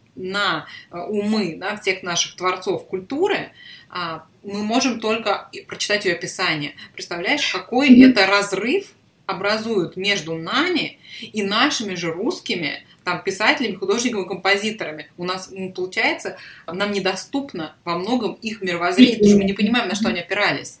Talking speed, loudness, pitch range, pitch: 135 wpm, -20 LUFS, 180-220 Hz, 200 Hz